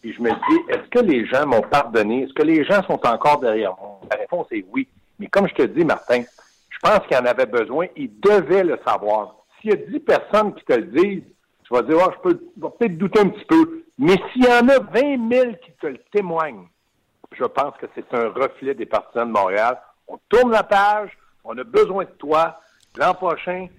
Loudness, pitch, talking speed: -19 LUFS, 210 Hz, 235 wpm